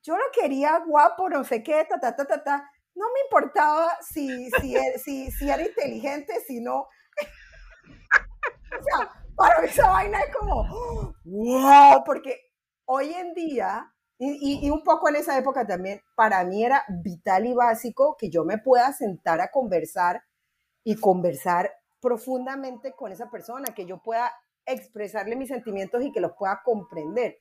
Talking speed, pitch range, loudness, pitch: 170 wpm, 215-290 Hz, -23 LUFS, 255 Hz